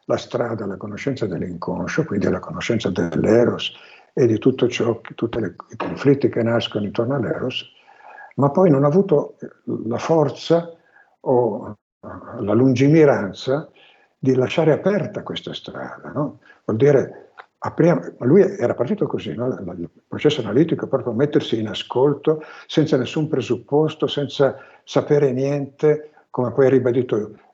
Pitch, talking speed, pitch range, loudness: 140 Hz, 140 wpm, 125-155 Hz, -20 LUFS